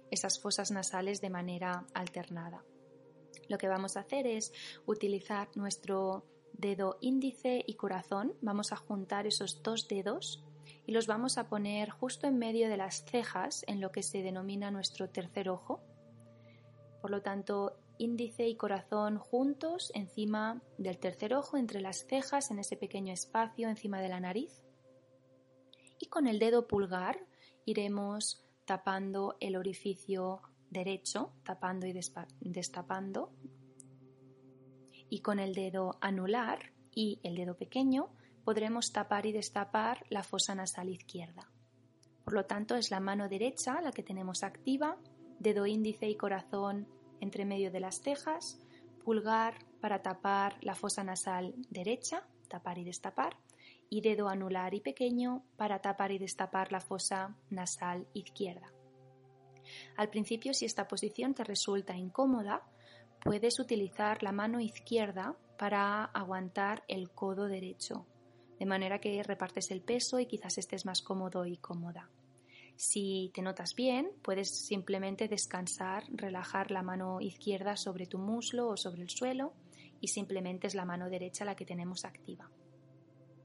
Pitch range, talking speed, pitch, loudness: 185-215 Hz, 140 wpm, 195 Hz, -37 LUFS